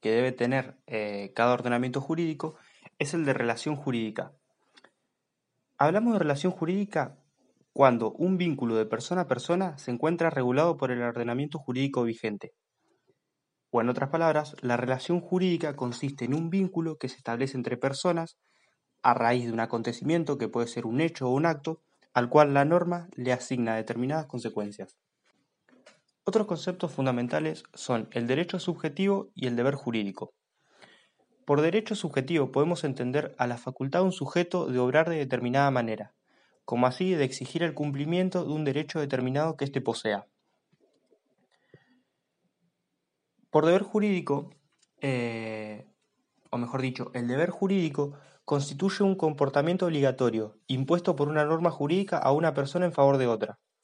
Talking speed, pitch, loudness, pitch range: 150 wpm, 140 Hz, -28 LUFS, 125-165 Hz